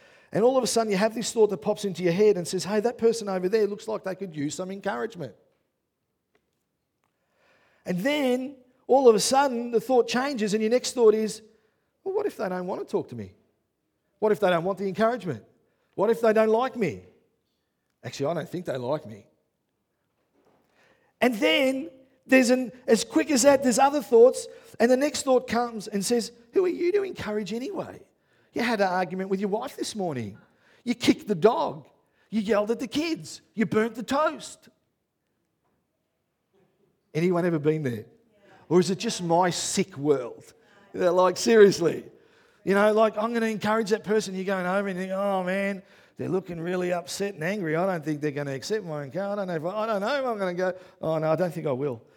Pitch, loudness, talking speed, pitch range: 215 Hz, -25 LUFS, 210 wpm, 185-245 Hz